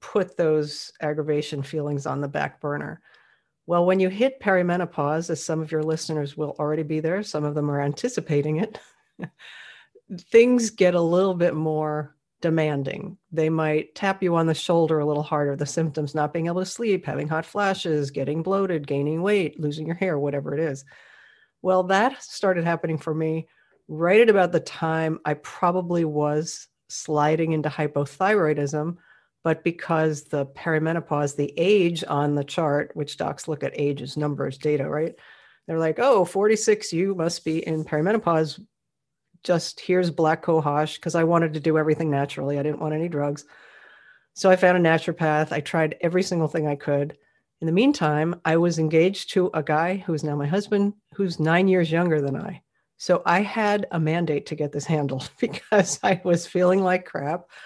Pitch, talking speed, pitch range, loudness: 160 Hz, 180 wpm, 150-180 Hz, -23 LUFS